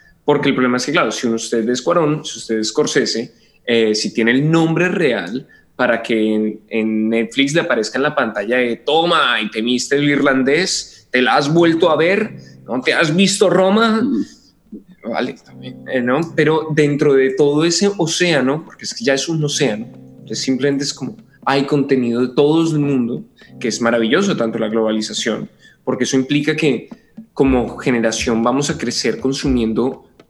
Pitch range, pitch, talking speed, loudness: 115-155 Hz, 135 Hz, 175 wpm, -16 LUFS